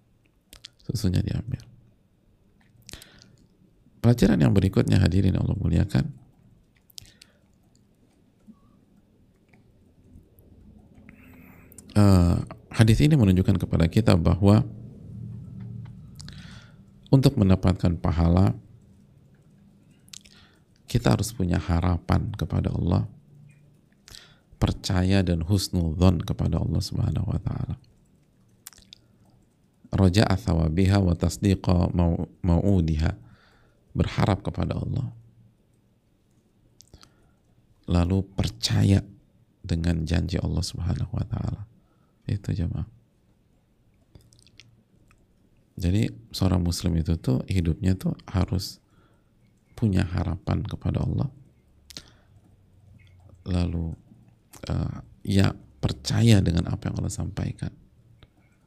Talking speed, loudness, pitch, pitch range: 70 wpm, -24 LUFS, 95 Hz, 90-110 Hz